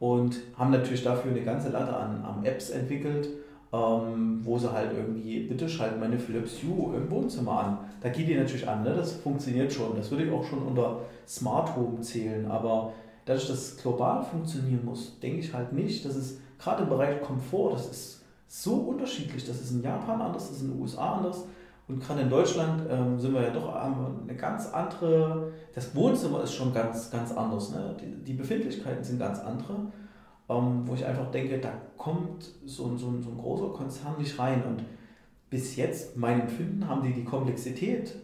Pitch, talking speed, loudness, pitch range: 130 Hz, 195 wpm, -31 LUFS, 120-150 Hz